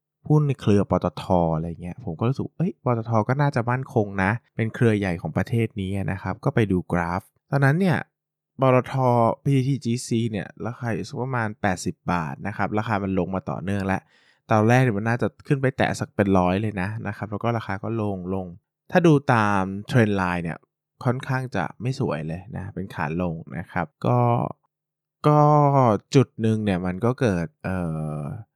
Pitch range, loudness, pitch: 95-130 Hz, -23 LUFS, 110 Hz